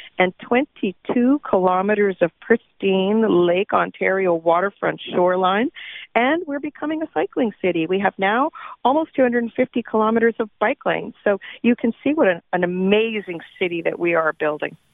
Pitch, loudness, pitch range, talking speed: 210 Hz, -20 LUFS, 185-245 Hz, 150 wpm